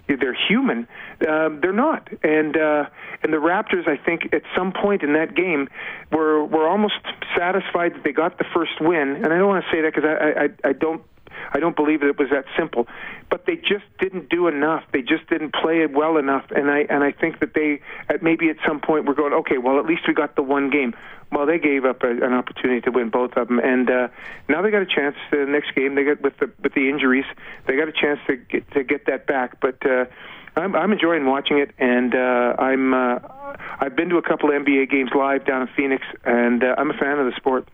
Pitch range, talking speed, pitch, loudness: 135-165 Hz, 245 wpm, 150 Hz, -20 LUFS